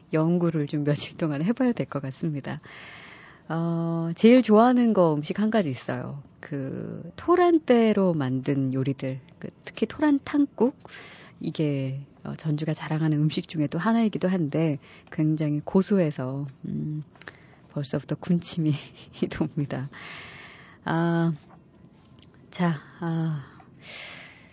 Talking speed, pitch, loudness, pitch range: 230 characters per minute, 160 Hz, -25 LUFS, 145-185 Hz